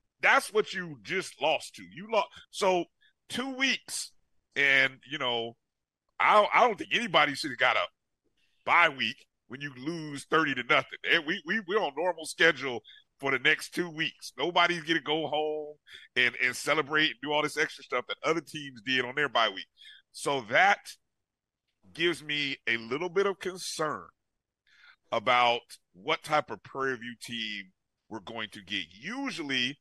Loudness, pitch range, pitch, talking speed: -28 LUFS, 125-165 Hz, 150 Hz, 175 wpm